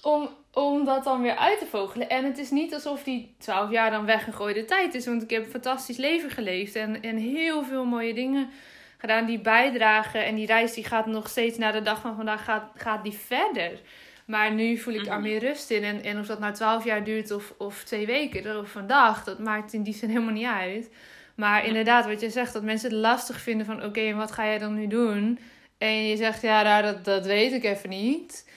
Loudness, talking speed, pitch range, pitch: -26 LUFS, 235 wpm, 215-245 Hz, 225 Hz